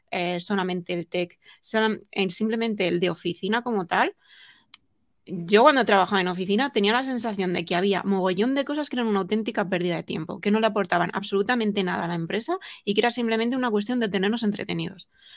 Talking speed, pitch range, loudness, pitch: 190 wpm, 180-225 Hz, -24 LUFS, 200 Hz